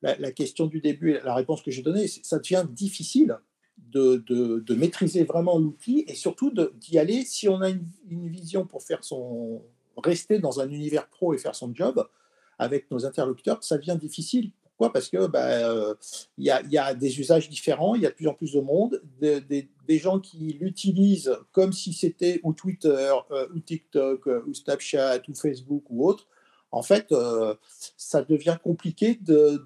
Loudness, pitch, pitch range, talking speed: -25 LUFS, 160 Hz, 140-185 Hz, 200 wpm